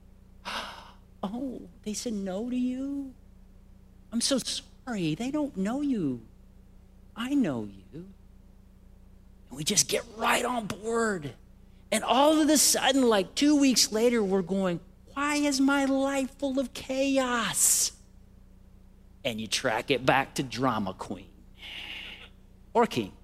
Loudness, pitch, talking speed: -27 LUFS, 205 Hz, 130 wpm